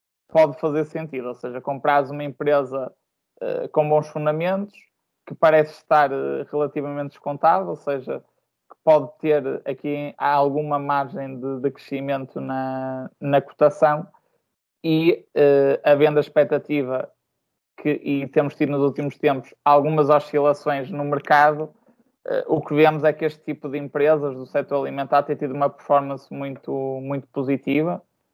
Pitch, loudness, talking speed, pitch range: 145 Hz, -22 LUFS, 140 wpm, 140-155 Hz